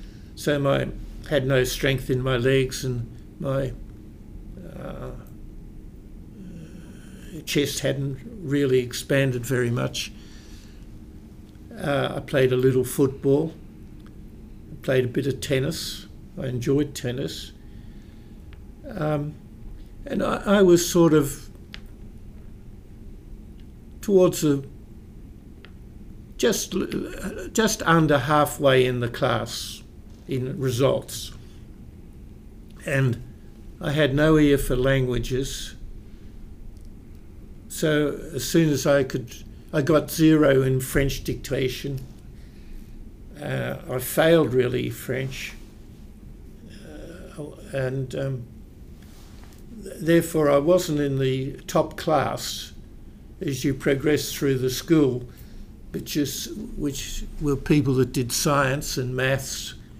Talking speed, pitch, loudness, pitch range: 100 wpm, 130 Hz, -23 LUFS, 110-145 Hz